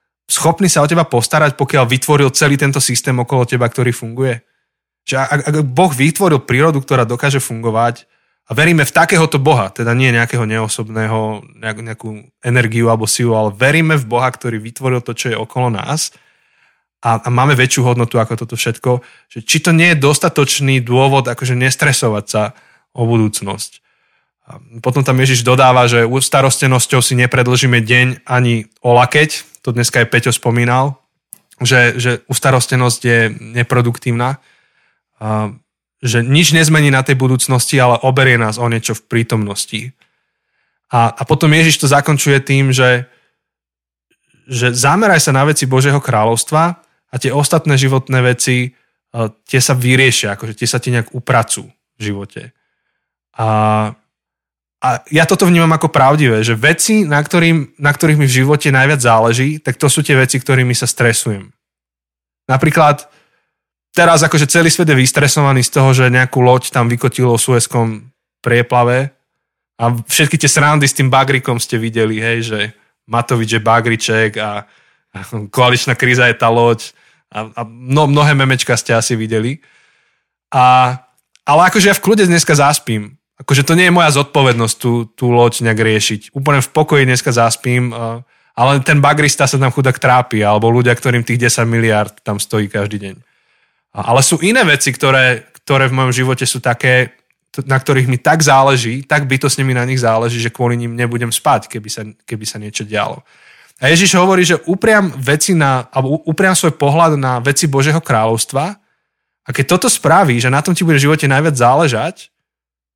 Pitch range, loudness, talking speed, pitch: 115-145 Hz, -12 LUFS, 165 wpm, 130 Hz